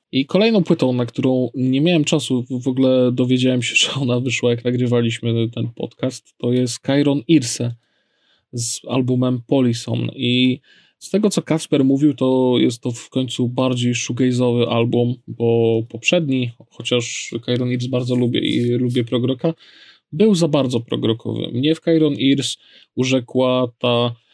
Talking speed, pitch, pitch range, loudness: 150 wpm, 125 Hz, 120-135 Hz, -18 LUFS